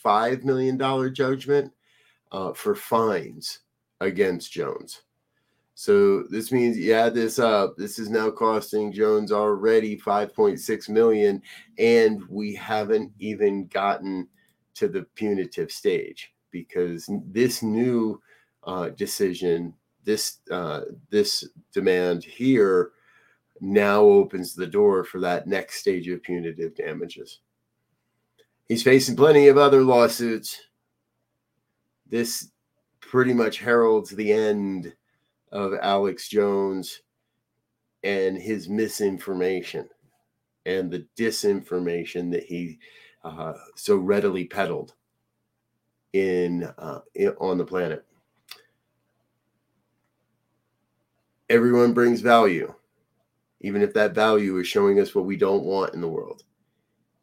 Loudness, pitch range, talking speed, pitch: -23 LUFS, 100-135 Hz, 110 wpm, 110 Hz